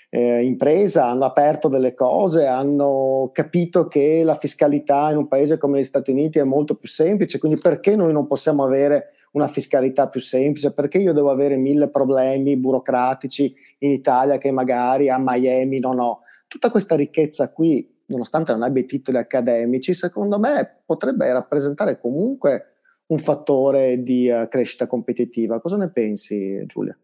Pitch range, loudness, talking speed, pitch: 130-155 Hz, -19 LUFS, 160 wpm, 140 Hz